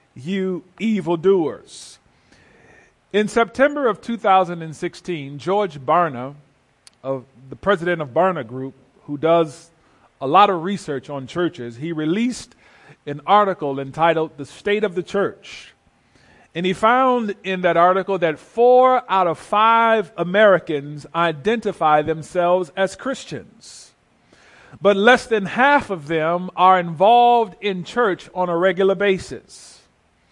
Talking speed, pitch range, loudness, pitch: 125 wpm, 155-205 Hz, -19 LUFS, 180 Hz